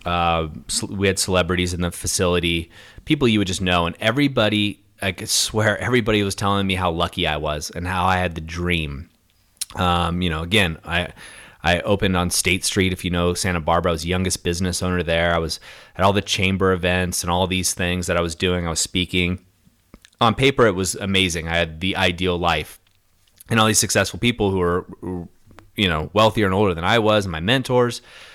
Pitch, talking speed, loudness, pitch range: 90 Hz, 210 wpm, -20 LUFS, 85-100 Hz